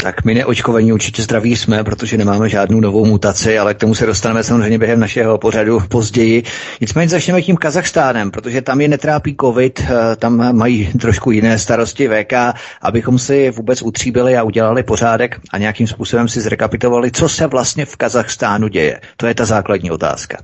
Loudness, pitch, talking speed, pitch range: -13 LUFS, 115 Hz, 175 wpm, 110-125 Hz